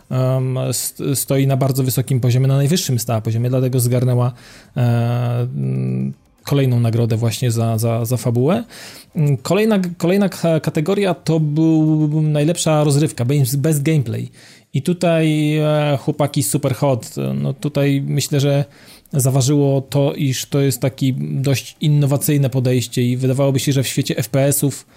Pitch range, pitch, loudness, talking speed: 125-150 Hz, 135 Hz, -17 LUFS, 125 wpm